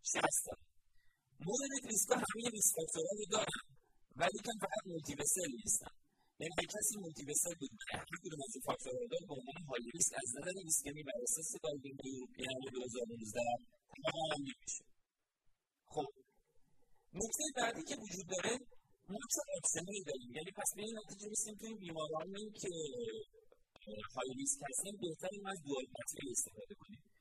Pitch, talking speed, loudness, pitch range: 185 Hz, 80 wpm, -40 LUFS, 140-220 Hz